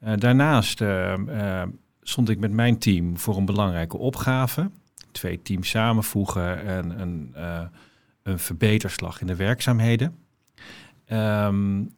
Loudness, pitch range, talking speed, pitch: -24 LUFS, 95-120 Hz, 125 wpm, 105 Hz